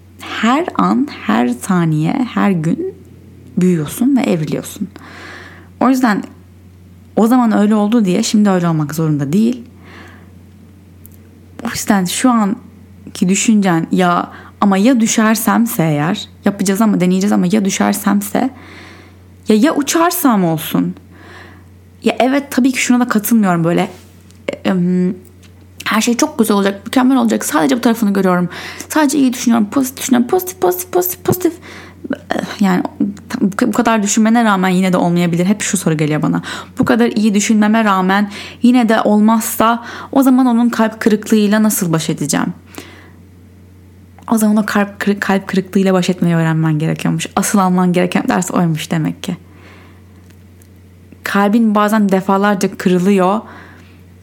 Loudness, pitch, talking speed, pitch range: -14 LUFS, 195 Hz, 135 wpm, 150-225 Hz